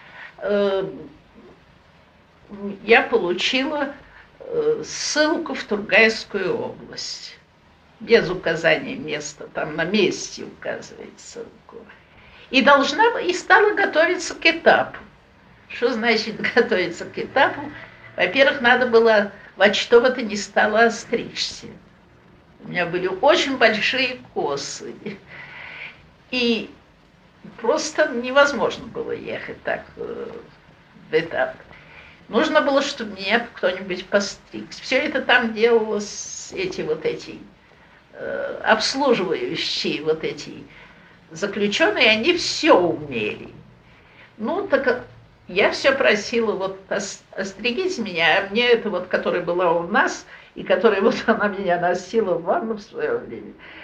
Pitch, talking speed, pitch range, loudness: 235 Hz, 110 wpm, 205-320 Hz, -20 LUFS